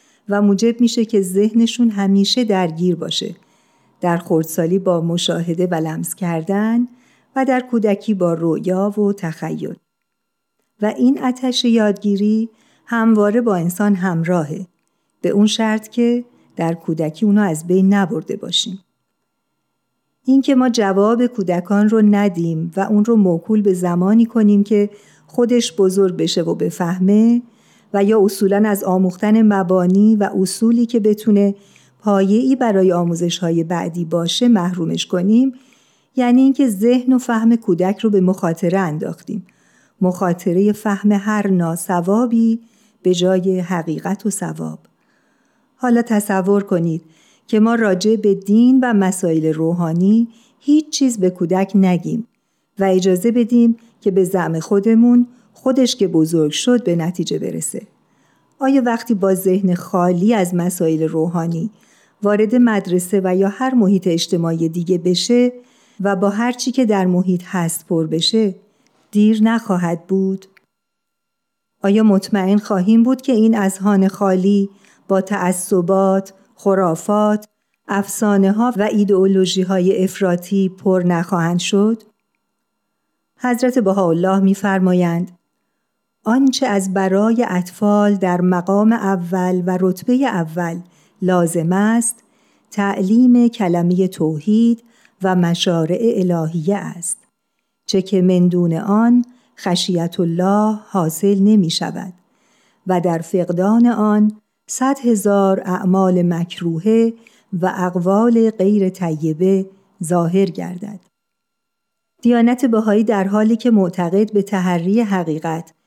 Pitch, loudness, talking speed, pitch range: 200 Hz, -16 LUFS, 120 wpm, 180-225 Hz